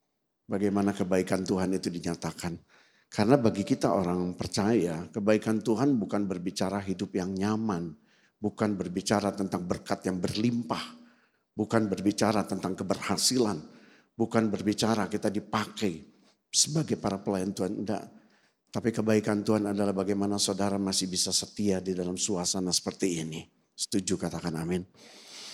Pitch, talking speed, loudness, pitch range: 100 Hz, 125 wpm, -29 LUFS, 95-105 Hz